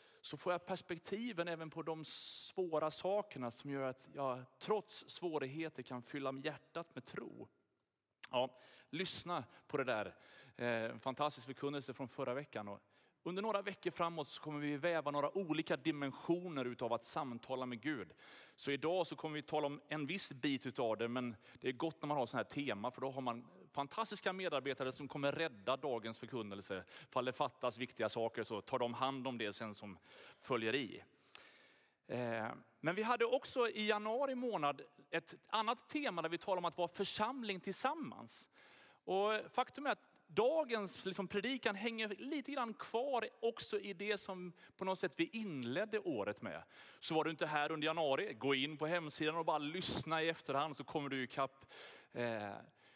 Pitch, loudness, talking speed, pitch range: 155 Hz, -41 LUFS, 180 wpm, 130-190 Hz